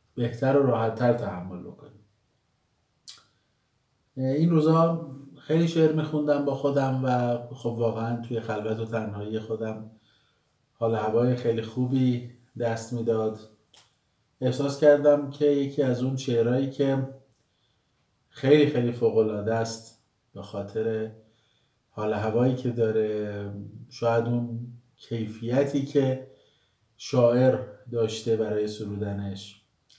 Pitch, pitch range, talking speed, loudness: 120 Hz, 110-135 Hz, 105 wpm, -26 LUFS